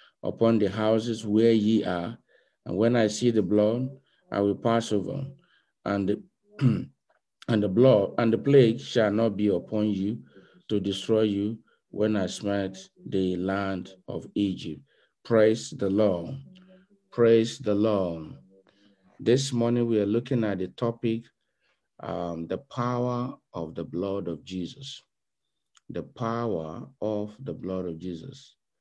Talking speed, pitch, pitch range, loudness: 140 wpm, 110 Hz, 95-120 Hz, -26 LUFS